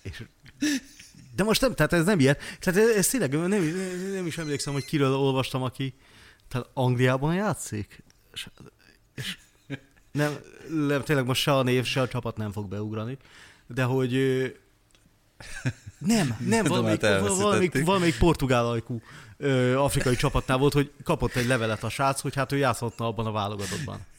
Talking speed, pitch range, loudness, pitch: 155 wpm, 120-150 Hz, -26 LUFS, 135 Hz